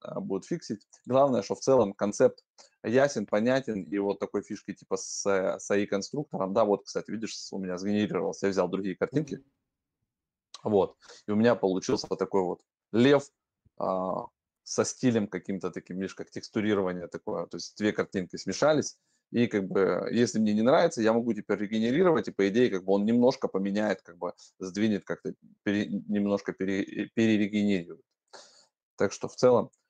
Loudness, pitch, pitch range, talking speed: -28 LUFS, 105 Hz, 95-115 Hz, 165 wpm